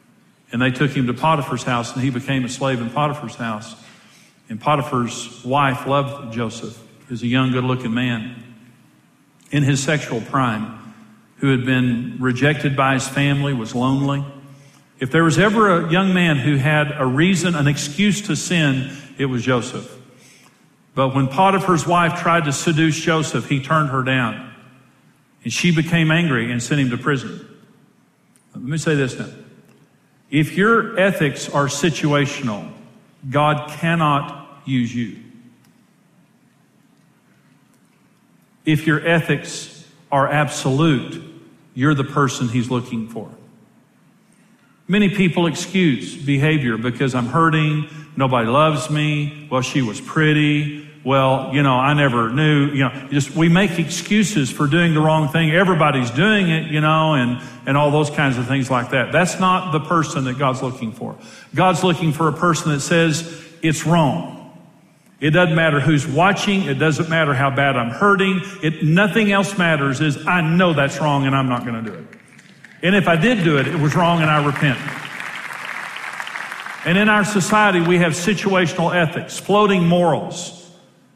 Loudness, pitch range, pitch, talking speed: -18 LUFS, 135-170 Hz, 150 Hz, 160 wpm